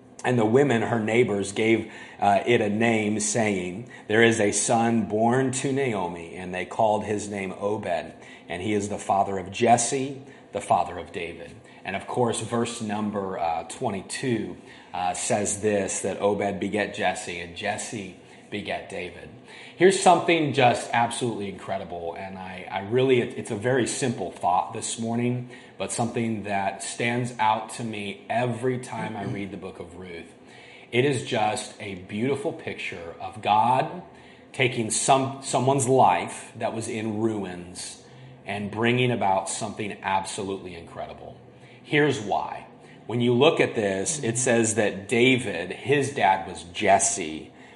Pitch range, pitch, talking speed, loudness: 100-120 Hz, 110 Hz, 150 wpm, -25 LUFS